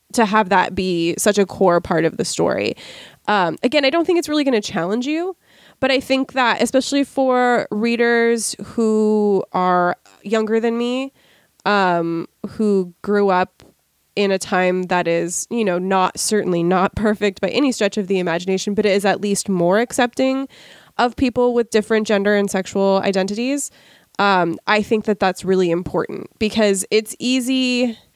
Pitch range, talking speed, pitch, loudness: 190-240 Hz, 170 wpm, 210 Hz, -18 LUFS